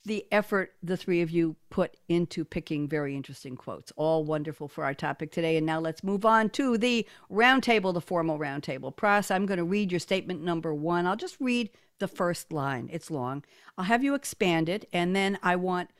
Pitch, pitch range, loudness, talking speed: 175 Hz, 160-200 Hz, -28 LUFS, 205 wpm